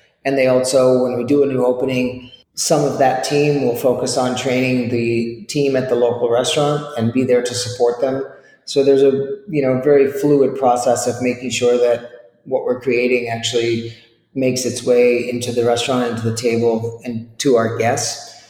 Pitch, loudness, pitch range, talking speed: 125 Hz, -17 LUFS, 120-135 Hz, 190 wpm